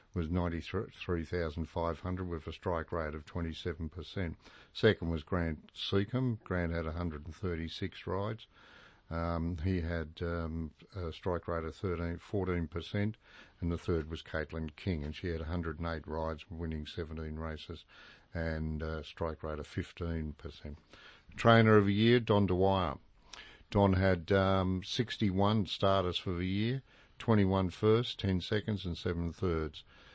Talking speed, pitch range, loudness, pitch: 135 wpm, 80-95 Hz, -34 LUFS, 85 Hz